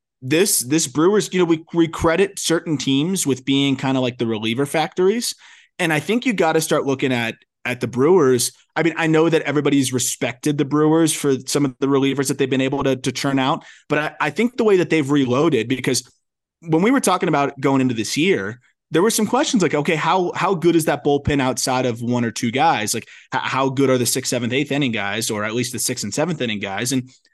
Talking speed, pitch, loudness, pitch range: 235 wpm, 140 Hz, -19 LUFS, 130-165 Hz